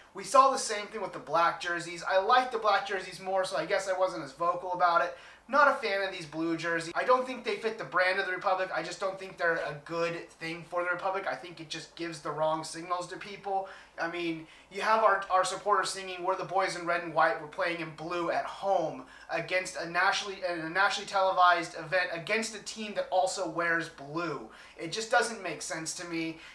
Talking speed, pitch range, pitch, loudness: 235 wpm, 170-195 Hz, 180 Hz, -30 LUFS